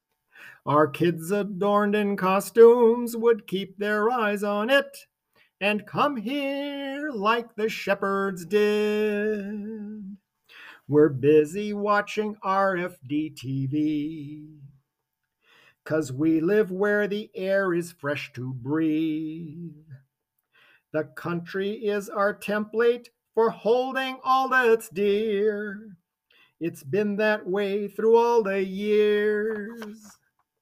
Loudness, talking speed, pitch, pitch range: -24 LUFS, 100 wpm, 205 Hz, 160-215 Hz